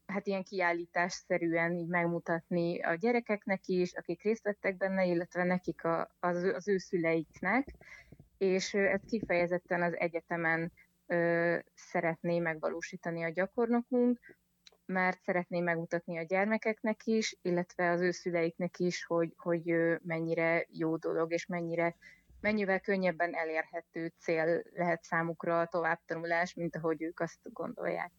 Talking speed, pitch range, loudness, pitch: 125 wpm, 170-190 Hz, -33 LUFS, 175 Hz